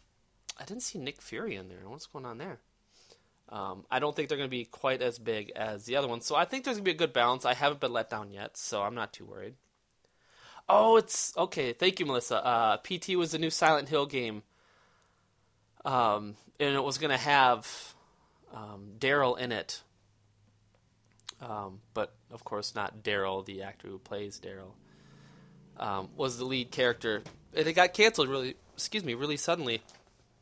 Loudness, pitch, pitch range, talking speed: -30 LUFS, 125 Hz, 105-150 Hz, 190 wpm